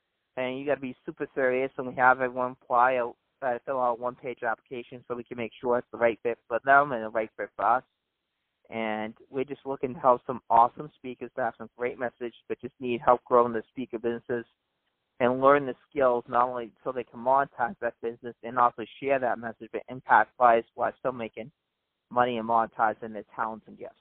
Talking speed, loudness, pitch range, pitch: 210 wpm, -27 LUFS, 115-130 Hz, 120 Hz